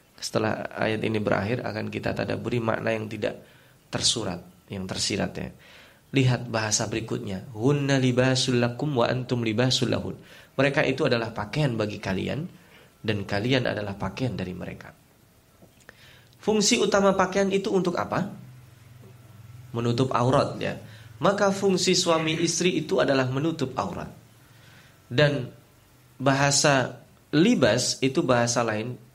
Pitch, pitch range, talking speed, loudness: 125 Hz, 115-140 Hz, 110 wpm, -25 LUFS